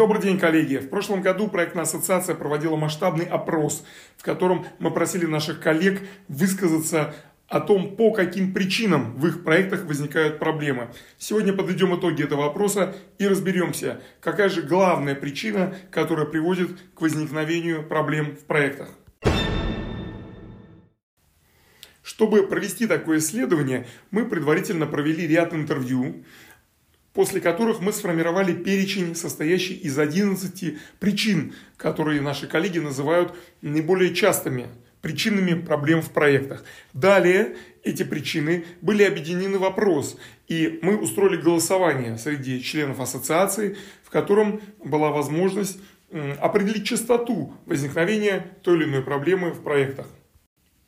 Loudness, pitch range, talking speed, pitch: -23 LUFS, 155-195 Hz, 120 wpm, 170 Hz